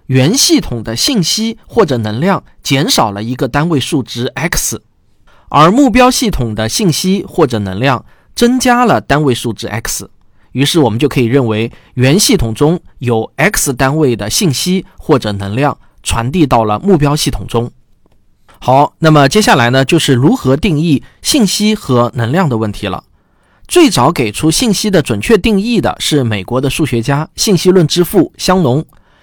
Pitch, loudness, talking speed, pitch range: 140 Hz, -11 LUFS, 250 characters per minute, 115-180 Hz